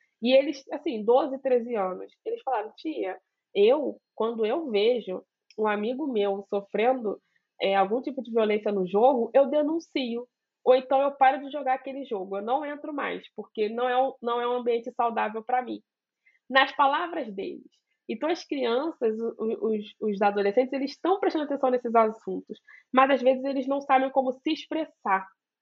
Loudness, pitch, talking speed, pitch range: -26 LUFS, 255 Hz, 170 wpm, 220-280 Hz